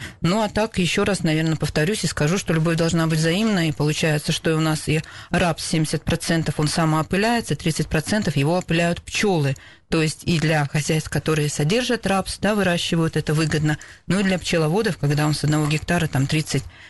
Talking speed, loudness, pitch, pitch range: 180 wpm, -21 LUFS, 160 Hz, 155-180 Hz